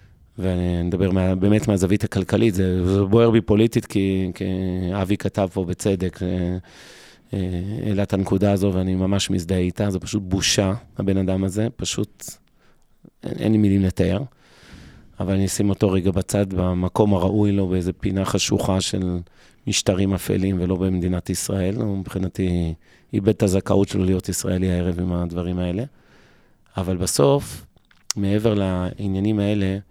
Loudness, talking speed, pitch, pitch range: -21 LUFS, 140 wpm, 95 Hz, 90-100 Hz